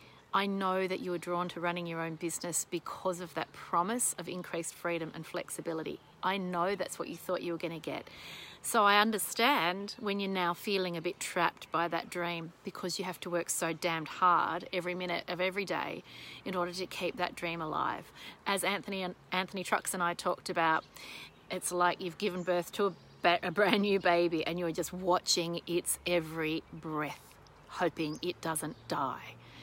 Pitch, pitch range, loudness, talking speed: 175 Hz, 170-185 Hz, -33 LUFS, 190 wpm